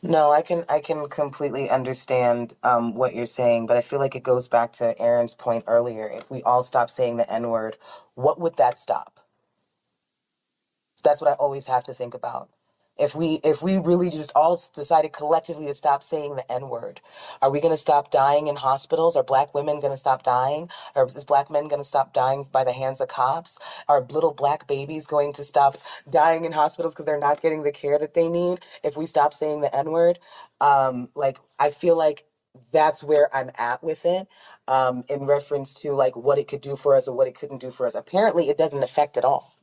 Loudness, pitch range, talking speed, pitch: -23 LUFS, 130-155 Hz, 215 wpm, 145 Hz